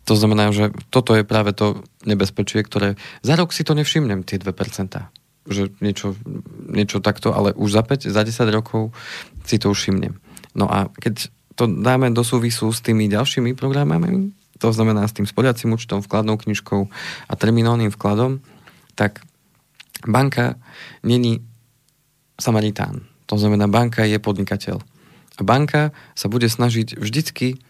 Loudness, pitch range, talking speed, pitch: -19 LUFS, 105-130 Hz, 145 wpm, 115 Hz